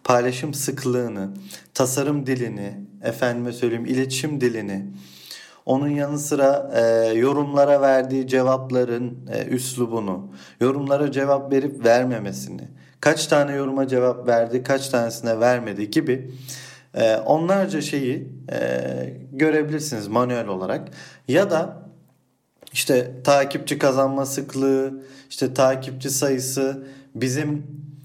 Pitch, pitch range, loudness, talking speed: 130 Hz, 115-140 Hz, -22 LUFS, 100 wpm